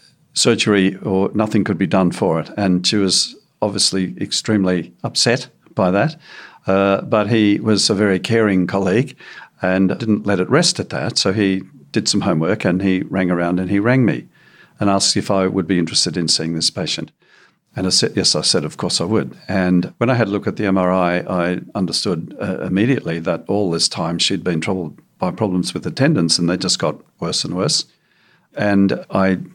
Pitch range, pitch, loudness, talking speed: 90-105 Hz, 95 Hz, -17 LUFS, 200 wpm